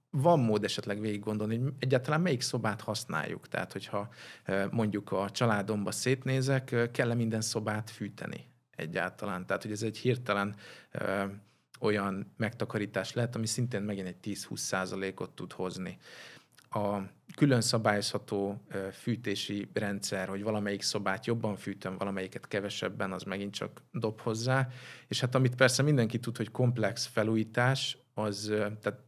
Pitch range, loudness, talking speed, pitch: 100-120 Hz, -32 LUFS, 130 wpm, 110 Hz